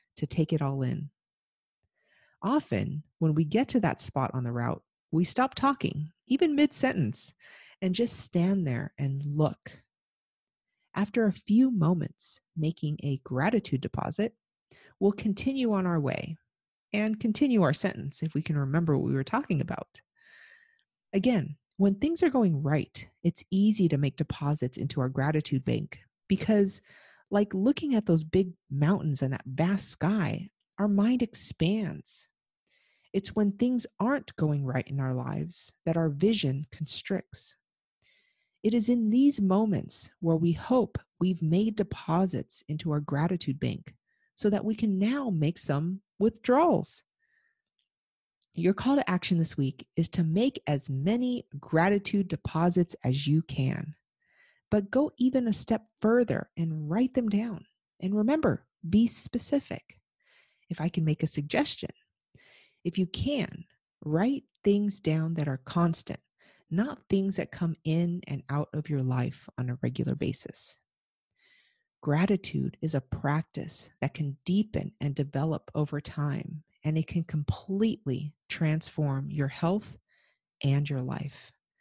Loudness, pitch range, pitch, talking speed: -29 LUFS, 150-215 Hz, 170 Hz, 145 wpm